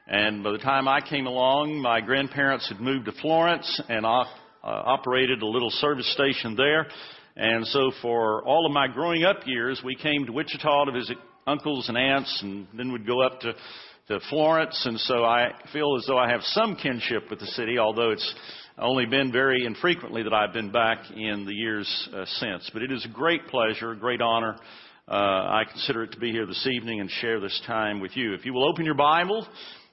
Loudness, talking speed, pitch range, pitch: -25 LUFS, 205 wpm, 115-140 Hz, 125 Hz